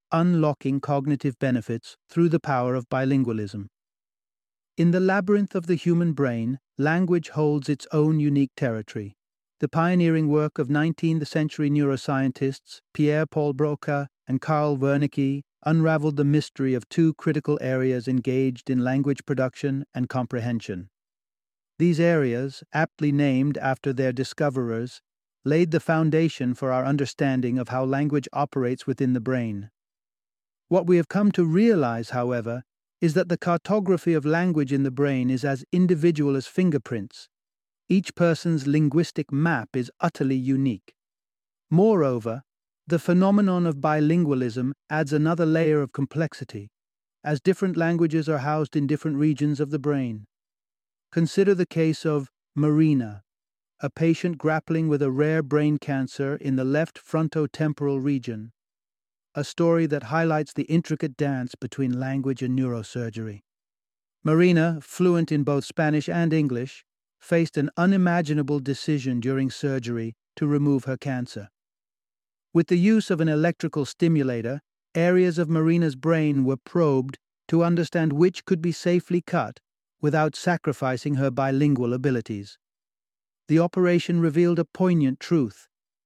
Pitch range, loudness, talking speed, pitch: 130-165 Hz, -24 LUFS, 135 wpm, 145 Hz